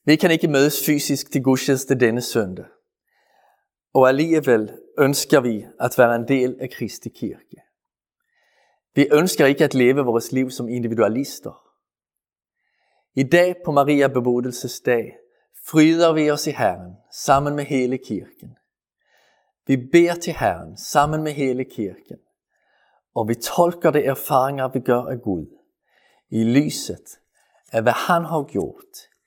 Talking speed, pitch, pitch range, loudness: 140 wpm, 135 Hz, 125-155 Hz, -20 LUFS